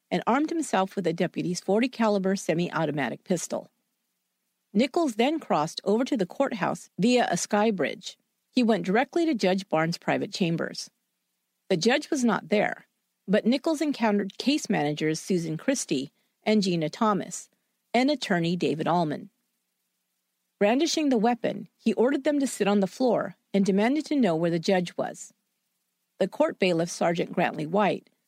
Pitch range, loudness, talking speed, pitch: 175-245 Hz, -26 LUFS, 155 wpm, 205 Hz